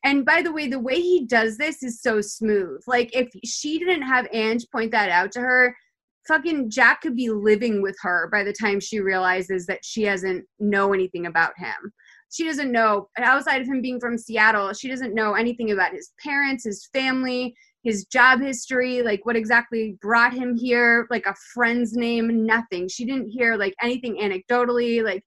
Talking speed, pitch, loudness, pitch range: 190 wpm, 235 Hz, -22 LUFS, 210-255 Hz